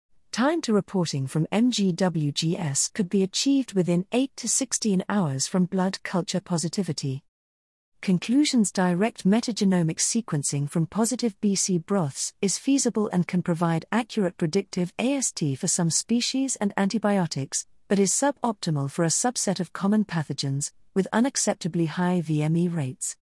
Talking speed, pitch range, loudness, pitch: 135 wpm, 165-215 Hz, -25 LUFS, 185 Hz